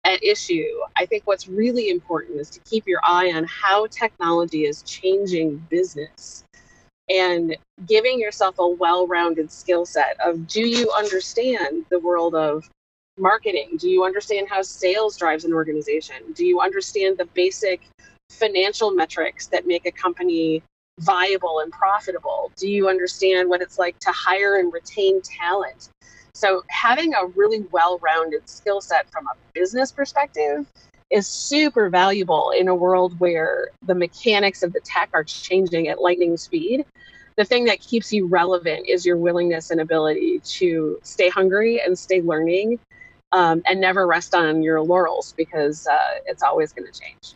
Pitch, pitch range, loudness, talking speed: 185 Hz, 170-220 Hz, -20 LUFS, 160 wpm